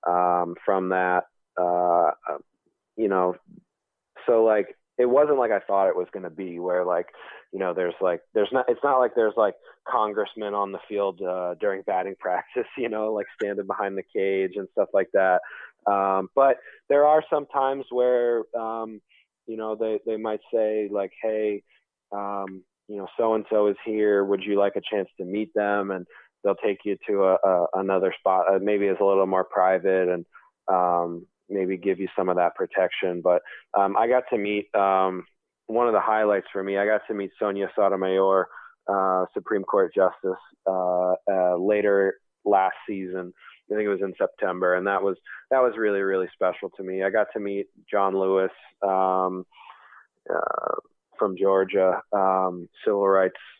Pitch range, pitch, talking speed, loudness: 95-105 Hz, 100 Hz, 180 wpm, -24 LUFS